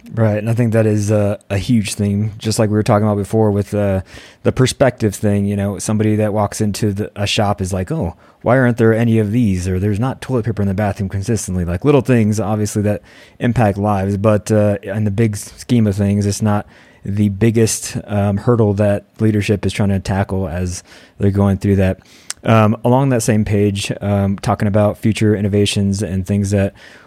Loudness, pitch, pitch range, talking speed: -16 LUFS, 105 Hz, 100-110 Hz, 210 wpm